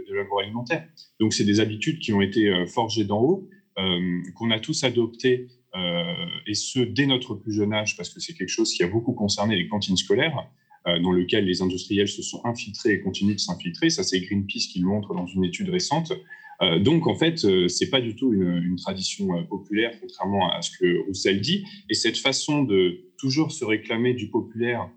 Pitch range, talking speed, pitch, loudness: 100-155 Hz, 210 wpm, 115 Hz, -24 LUFS